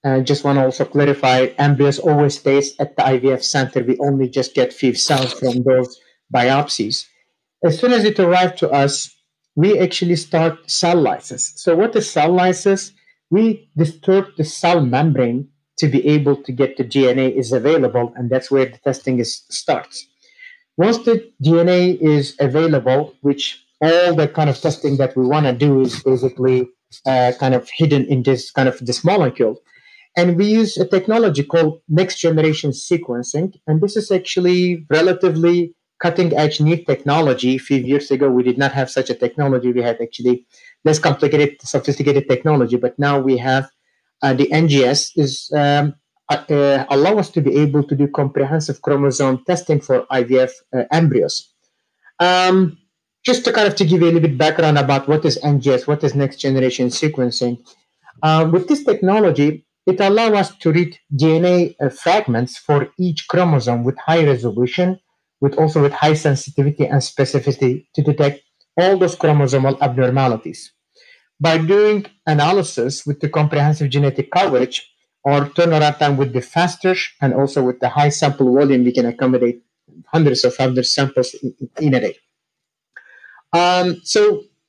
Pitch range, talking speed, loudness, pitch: 130-170 Hz, 165 wpm, -16 LUFS, 145 Hz